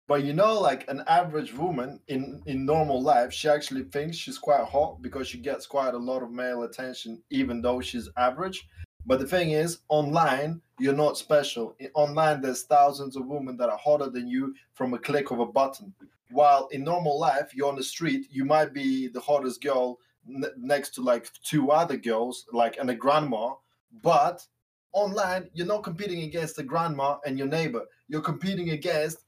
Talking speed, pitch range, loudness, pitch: 190 wpm, 130-155 Hz, -27 LUFS, 145 Hz